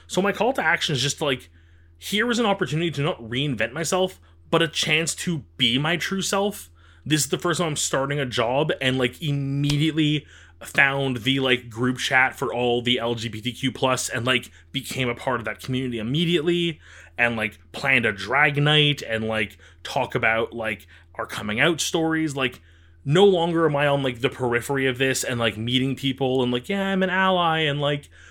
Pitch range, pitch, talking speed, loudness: 115-160 Hz, 135 Hz, 195 wpm, -22 LUFS